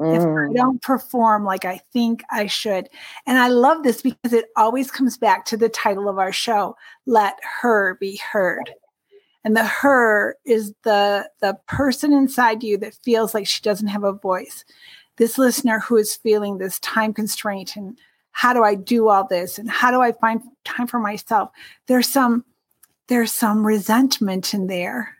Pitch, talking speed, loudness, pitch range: 225 Hz, 180 wpm, -19 LUFS, 205-250 Hz